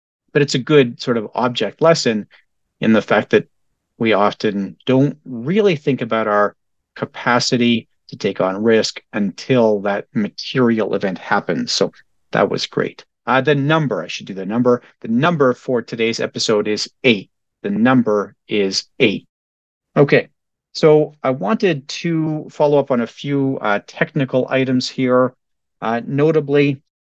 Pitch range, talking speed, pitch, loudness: 110-150 Hz, 150 wpm, 125 Hz, -17 LUFS